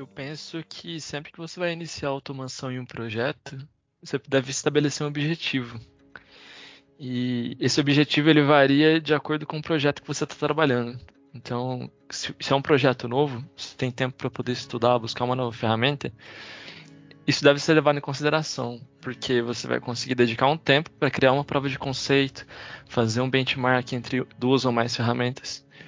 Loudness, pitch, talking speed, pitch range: -24 LUFS, 135 Hz, 175 wpm, 125-150 Hz